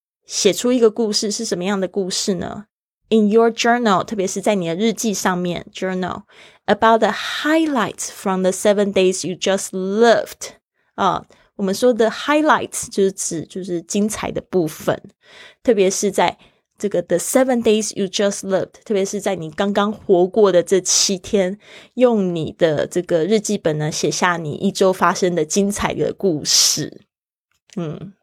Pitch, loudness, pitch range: 200 Hz, -18 LUFS, 185-220 Hz